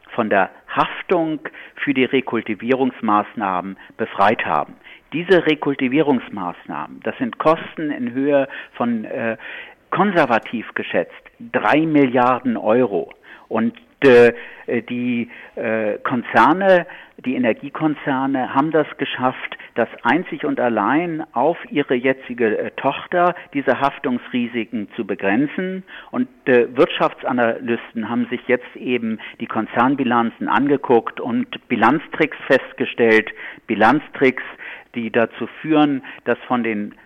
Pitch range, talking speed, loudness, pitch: 120-160 Hz, 100 wpm, -19 LUFS, 130 Hz